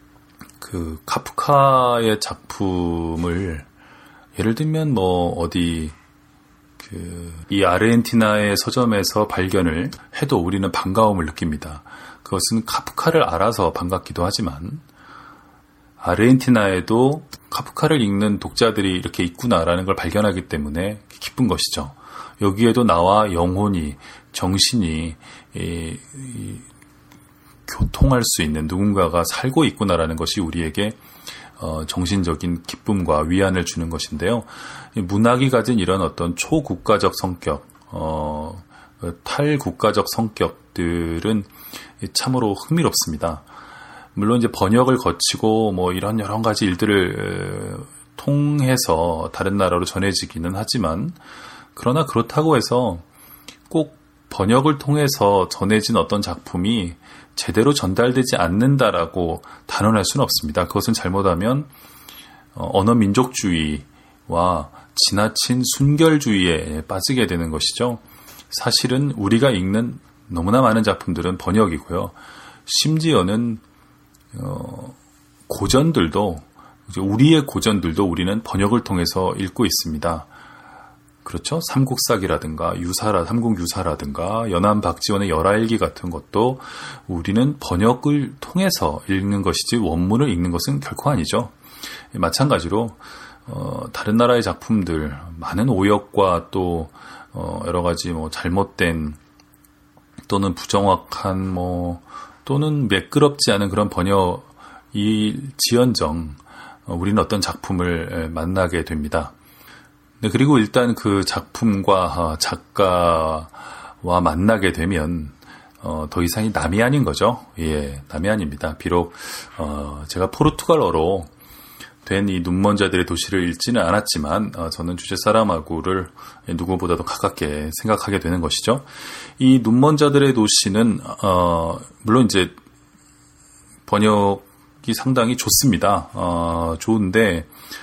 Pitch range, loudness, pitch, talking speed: 85-115 Hz, -19 LUFS, 95 Hz, 260 characters per minute